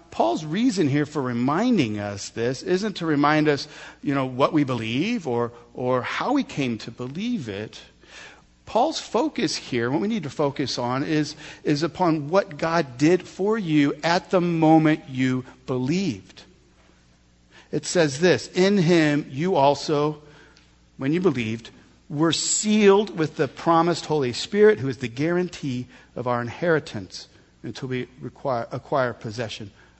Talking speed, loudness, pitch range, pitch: 150 wpm, -23 LUFS, 125-170 Hz, 145 Hz